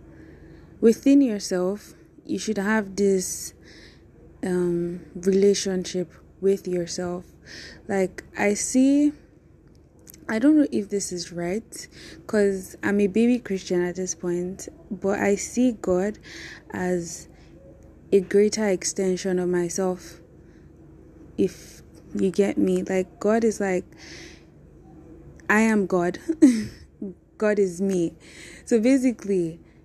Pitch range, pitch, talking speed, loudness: 180-210 Hz, 195 Hz, 110 wpm, -23 LUFS